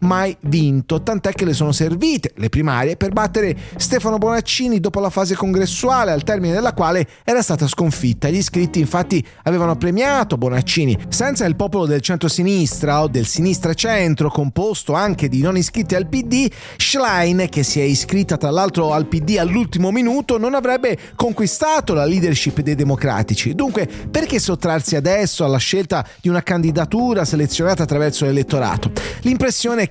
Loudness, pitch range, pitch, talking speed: -17 LUFS, 150-210 Hz, 175 Hz, 155 wpm